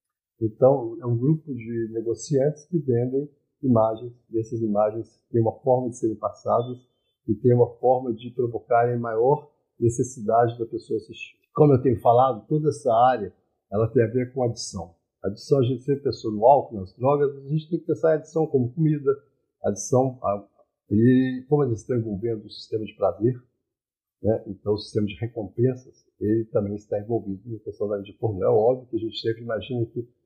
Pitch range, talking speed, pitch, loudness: 115-140 Hz, 180 wpm, 120 Hz, -24 LUFS